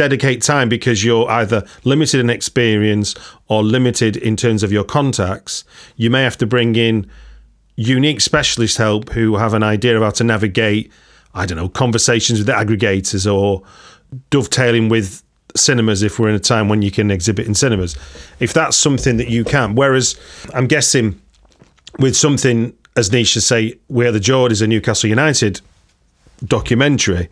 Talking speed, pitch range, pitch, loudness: 165 wpm, 105-125 Hz, 115 Hz, -15 LUFS